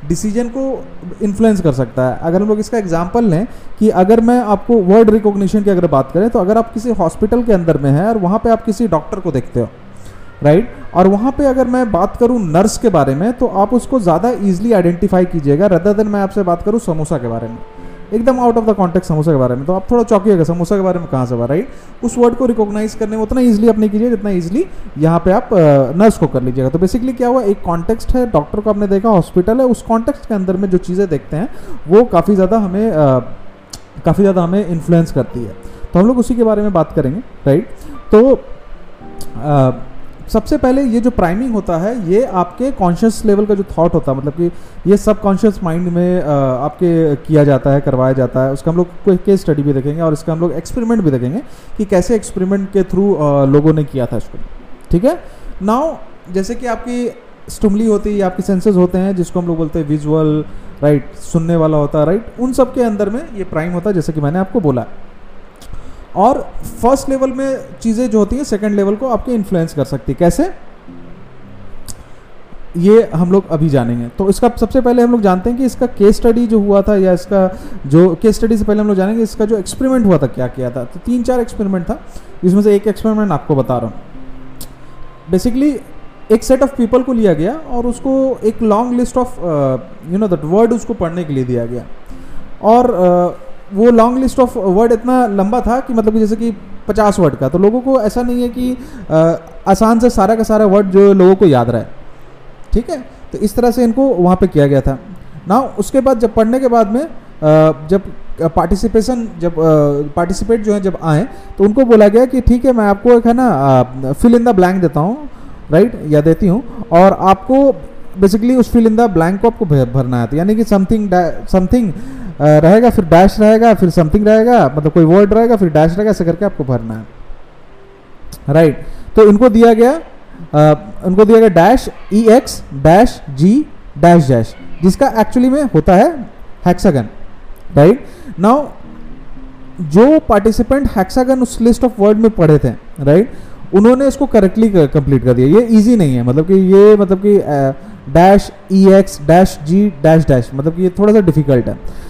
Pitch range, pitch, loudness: 160-230 Hz, 195 Hz, -12 LUFS